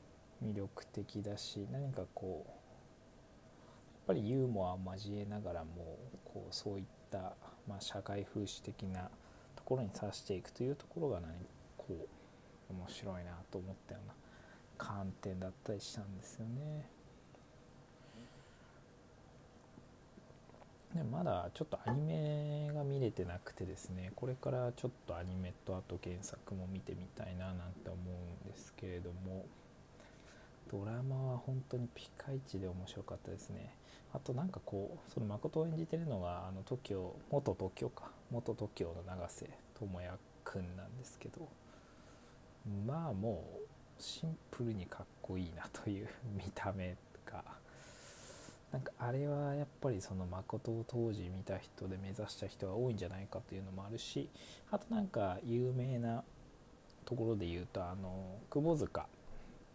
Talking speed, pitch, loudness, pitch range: 285 characters per minute, 100 Hz, -43 LUFS, 95-125 Hz